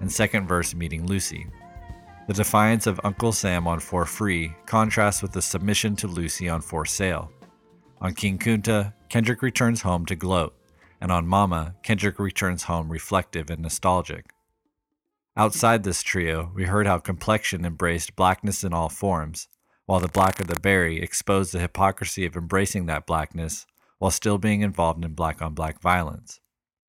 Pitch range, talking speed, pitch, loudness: 85-100 Hz, 165 wpm, 95 Hz, -24 LUFS